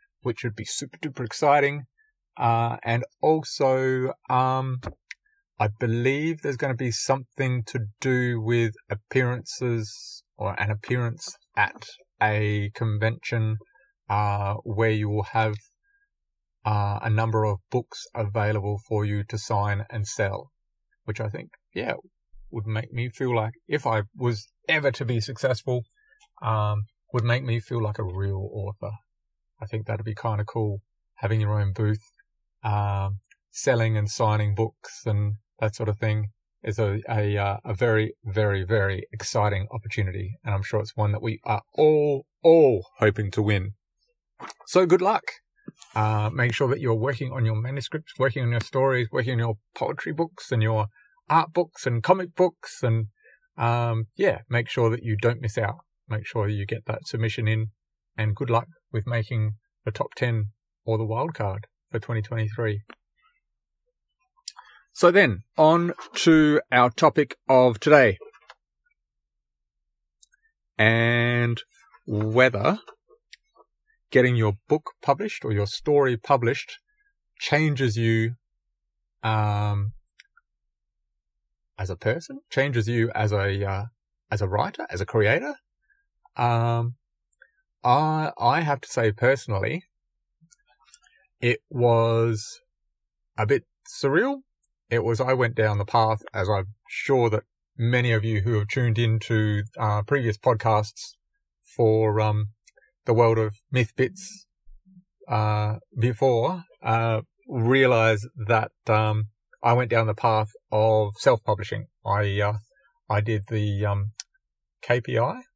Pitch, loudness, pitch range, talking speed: 115 Hz, -25 LUFS, 105-135 Hz, 140 wpm